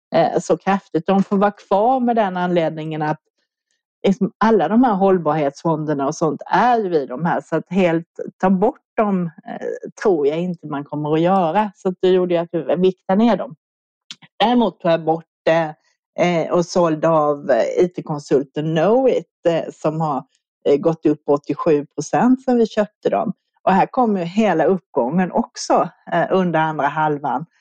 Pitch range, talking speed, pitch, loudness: 155-205 Hz, 165 wpm, 175 Hz, -19 LUFS